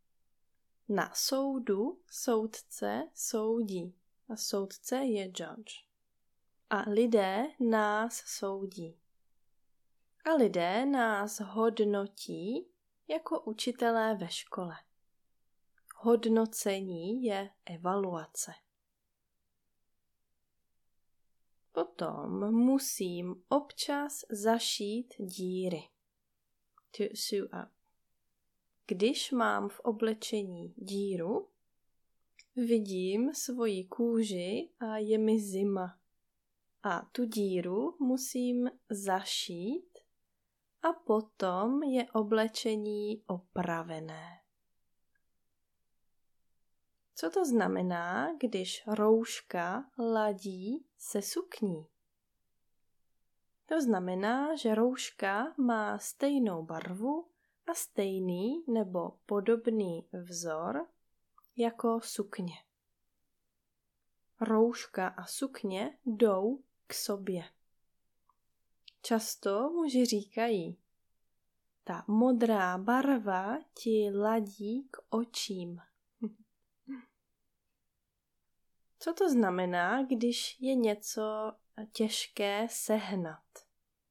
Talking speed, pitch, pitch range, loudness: 70 wpm, 220 Hz, 190-245 Hz, -33 LUFS